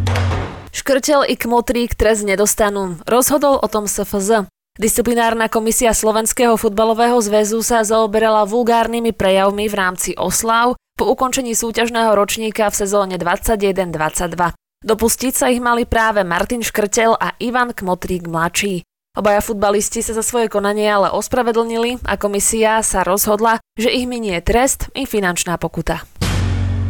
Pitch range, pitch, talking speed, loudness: 195-230 Hz, 220 Hz, 130 wpm, -16 LUFS